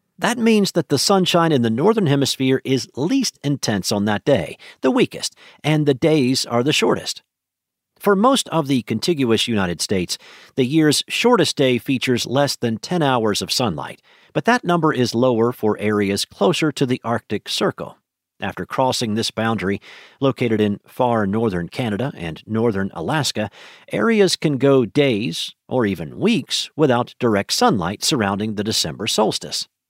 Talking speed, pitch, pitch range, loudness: 160 wpm, 130 Hz, 110-155 Hz, -19 LUFS